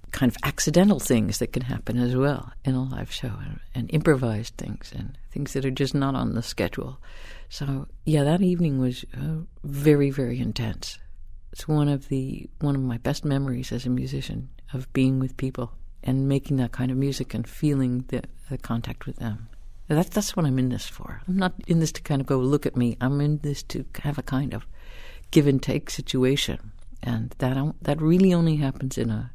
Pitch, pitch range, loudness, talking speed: 130 Hz, 125-145 Hz, -25 LUFS, 210 wpm